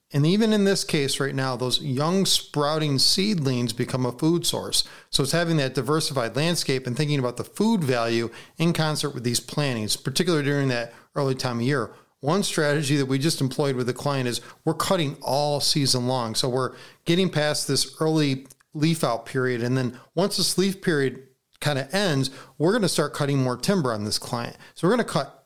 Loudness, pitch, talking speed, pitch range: -24 LUFS, 140 Hz, 205 wpm, 130-160 Hz